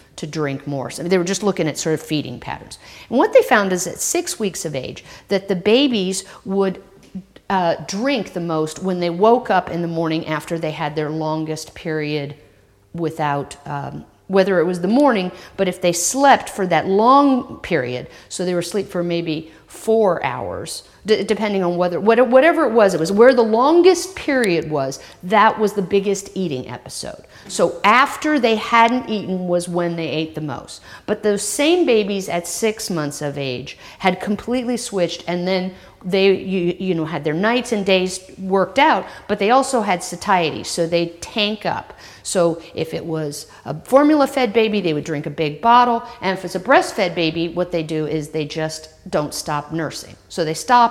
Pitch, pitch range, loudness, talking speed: 185 Hz, 160-215 Hz, -18 LUFS, 195 wpm